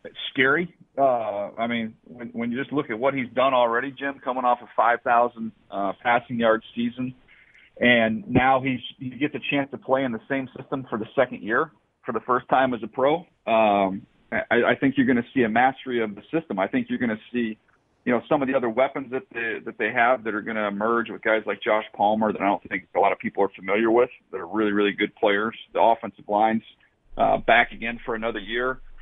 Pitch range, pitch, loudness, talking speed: 110-135 Hz, 120 Hz, -24 LUFS, 235 wpm